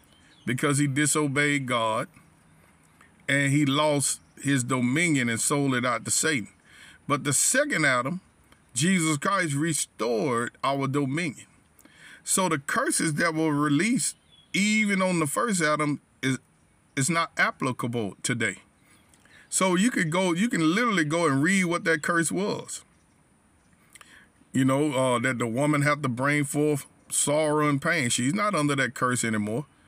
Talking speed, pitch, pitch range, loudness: 145 wpm, 145 Hz, 130-165 Hz, -25 LUFS